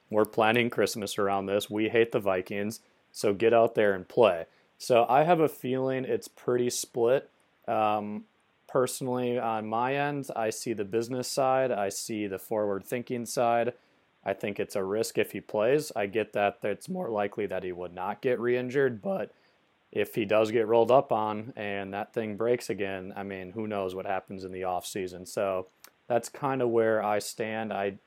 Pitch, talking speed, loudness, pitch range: 110 Hz, 190 wpm, -29 LUFS, 100-125 Hz